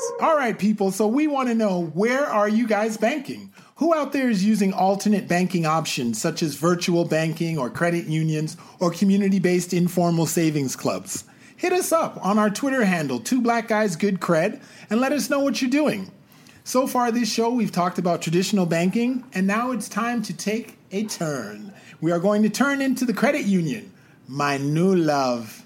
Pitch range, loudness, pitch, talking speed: 170-235 Hz, -22 LUFS, 200 Hz, 190 wpm